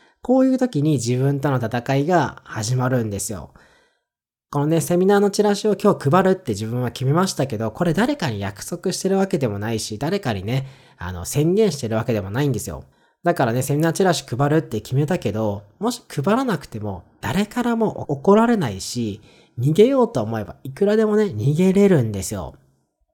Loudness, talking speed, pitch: -20 LUFS, 380 characters per minute, 140 Hz